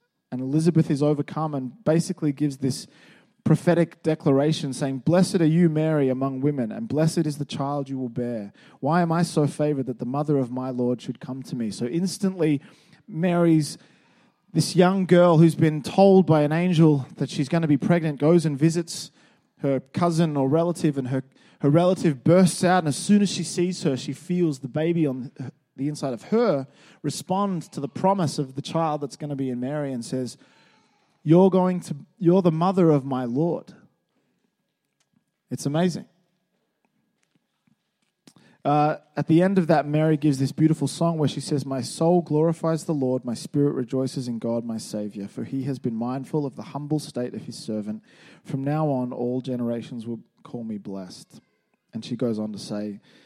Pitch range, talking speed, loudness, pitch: 135-170 Hz, 190 wpm, -23 LUFS, 150 Hz